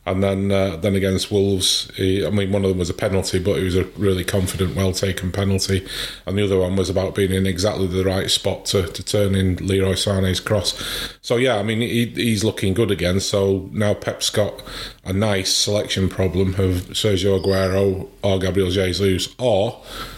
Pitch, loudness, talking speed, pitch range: 95 Hz, -20 LUFS, 200 wpm, 95-100 Hz